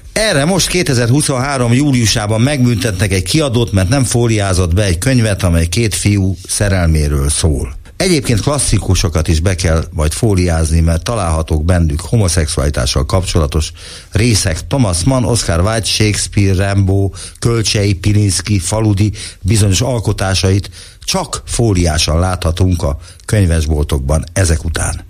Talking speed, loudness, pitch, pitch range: 115 wpm, -13 LUFS, 95 Hz, 85-110 Hz